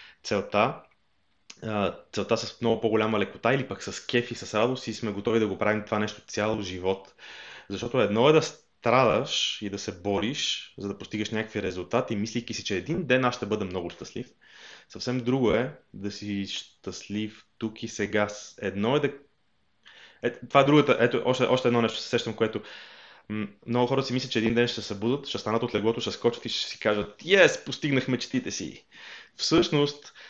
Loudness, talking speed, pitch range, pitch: -27 LUFS, 190 wpm, 105-125 Hz, 110 Hz